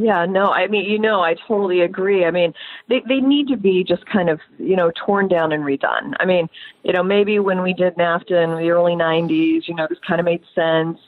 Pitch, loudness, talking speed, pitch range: 175 Hz, -18 LUFS, 250 wpm, 165-200 Hz